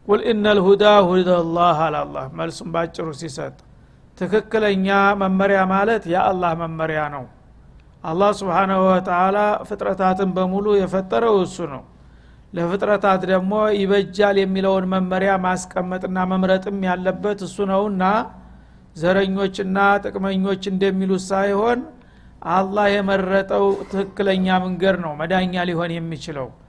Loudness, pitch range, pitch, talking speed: -19 LUFS, 175-195 Hz, 190 Hz, 100 wpm